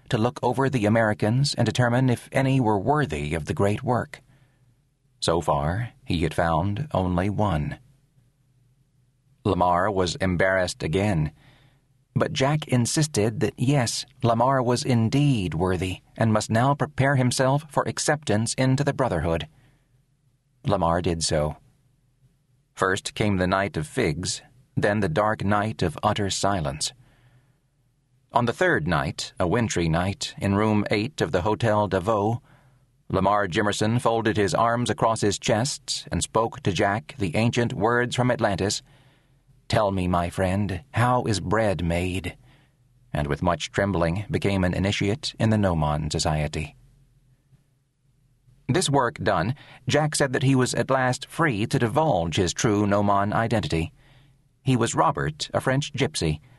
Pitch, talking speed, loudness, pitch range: 120 Hz, 145 wpm, -24 LUFS, 100-135 Hz